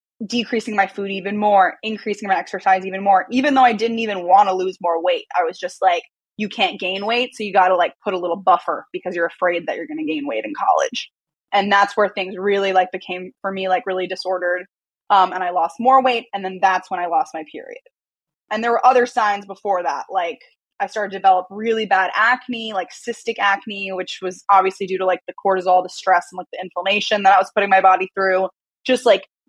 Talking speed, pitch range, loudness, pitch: 235 wpm, 185-220 Hz, -19 LUFS, 195 Hz